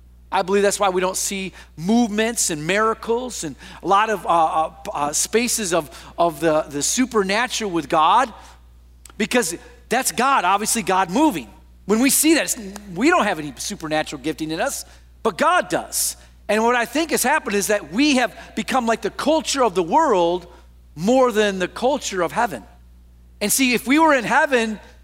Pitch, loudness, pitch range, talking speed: 205 Hz, -19 LUFS, 160-240 Hz, 180 wpm